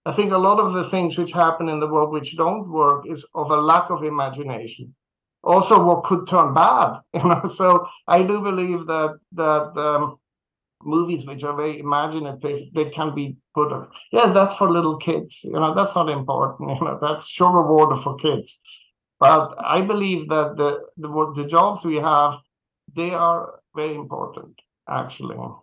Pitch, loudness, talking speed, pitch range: 155 Hz, -20 LUFS, 180 wpm, 150-175 Hz